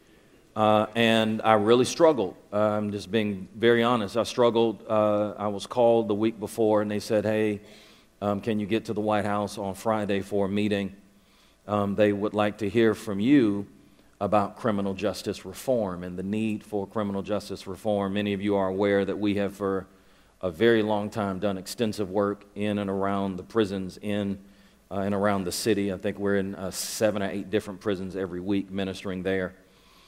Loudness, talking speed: -26 LUFS, 195 wpm